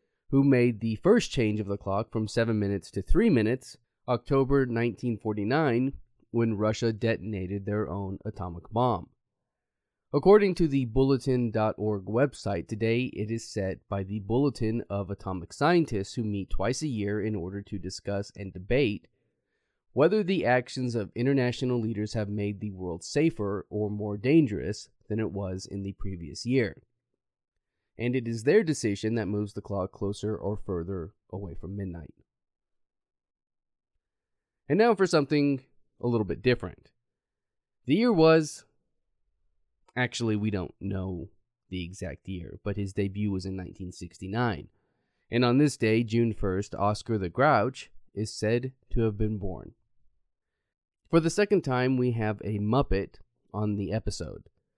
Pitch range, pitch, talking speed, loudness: 100-125 Hz, 105 Hz, 150 wpm, -28 LUFS